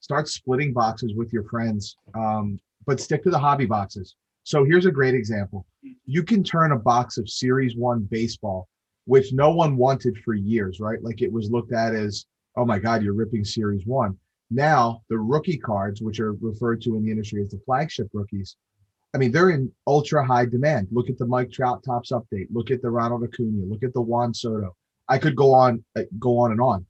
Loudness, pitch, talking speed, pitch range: -23 LUFS, 115 Hz, 210 wpm, 105-130 Hz